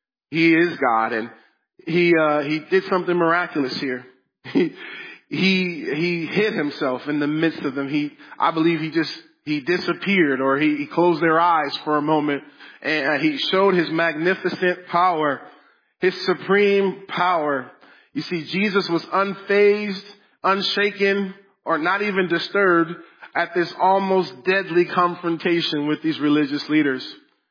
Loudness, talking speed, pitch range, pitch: -21 LUFS, 140 wpm, 155-190 Hz, 175 Hz